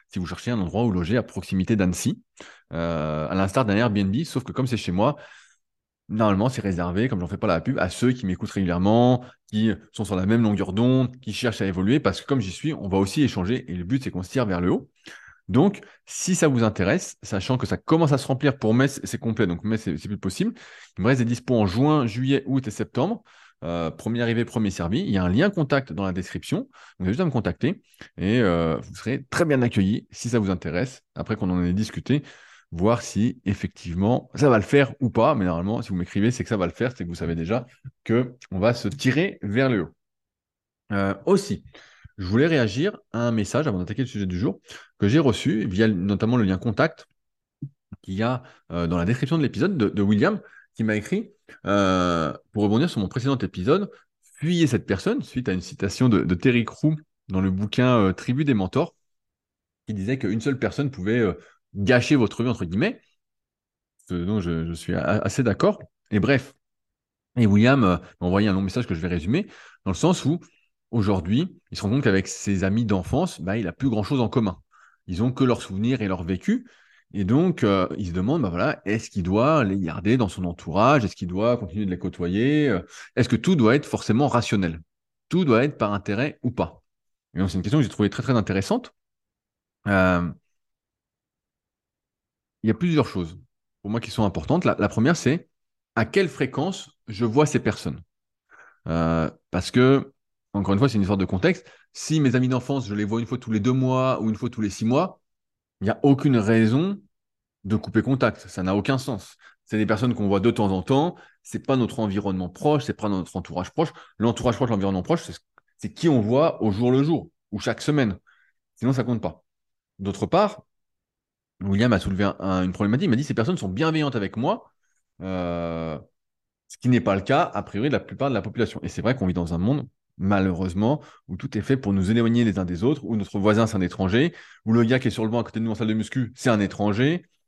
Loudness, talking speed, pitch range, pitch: -23 LUFS, 230 wpm, 95-130 Hz, 110 Hz